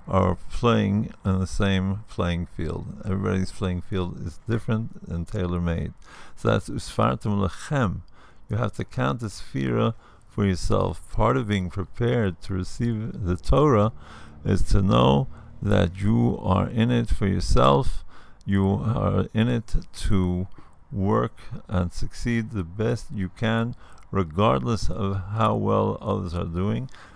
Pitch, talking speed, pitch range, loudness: 100 Hz, 140 wpm, 90-115 Hz, -25 LUFS